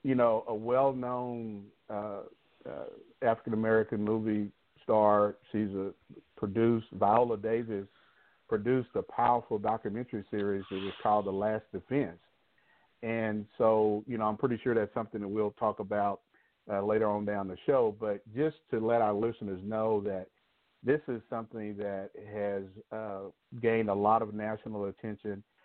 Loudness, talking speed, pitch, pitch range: -32 LUFS, 155 wpm, 110 Hz, 105-115 Hz